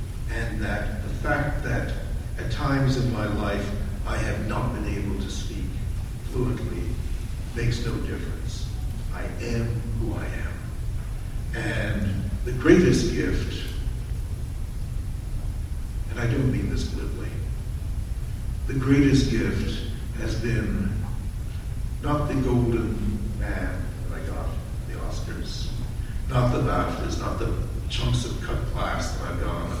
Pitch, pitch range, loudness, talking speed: 110 Hz, 100-115 Hz, -27 LUFS, 125 wpm